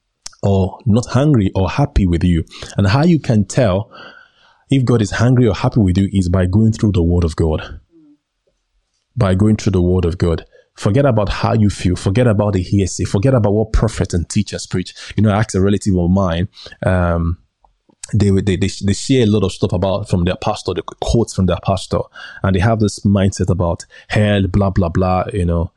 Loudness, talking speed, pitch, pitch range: -16 LUFS, 210 wpm, 100 Hz, 90-110 Hz